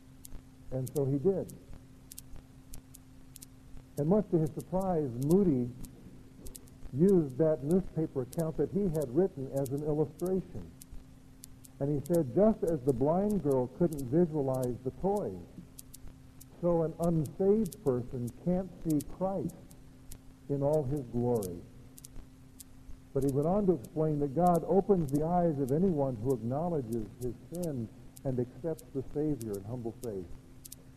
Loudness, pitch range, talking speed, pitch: -32 LUFS, 125-170 Hz, 130 wpm, 145 Hz